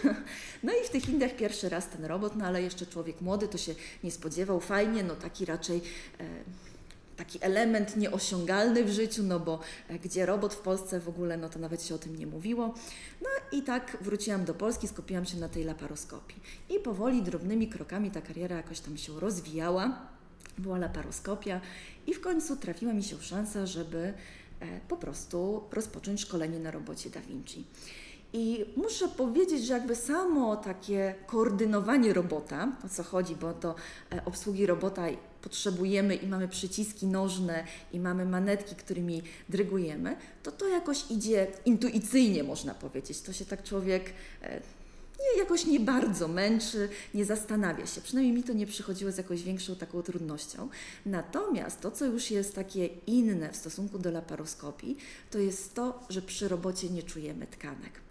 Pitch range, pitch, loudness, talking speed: 175-220 Hz, 195 Hz, -33 LUFS, 165 wpm